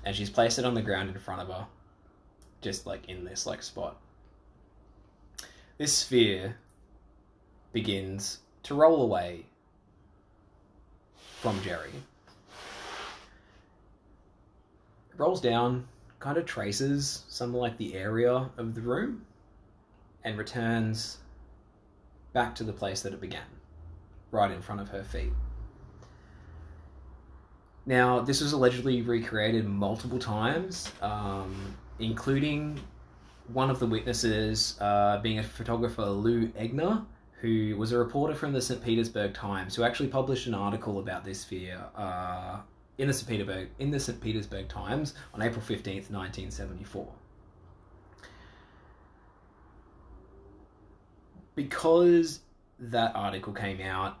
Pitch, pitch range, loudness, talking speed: 105 Hz, 95-120 Hz, -30 LUFS, 120 wpm